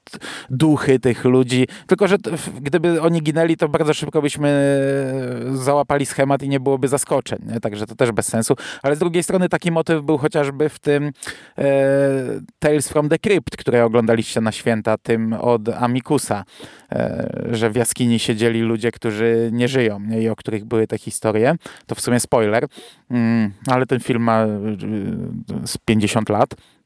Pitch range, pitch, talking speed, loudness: 115-145 Hz, 130 Hz, 170 wpm, -19 LUFS